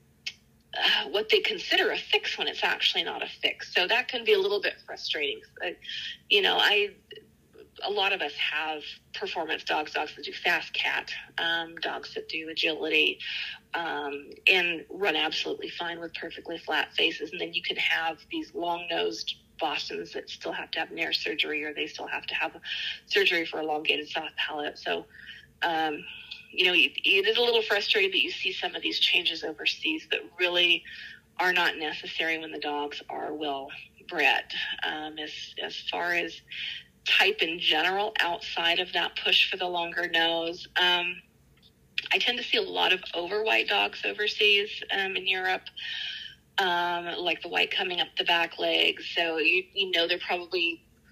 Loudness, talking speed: -26 LUFS, 180 wpm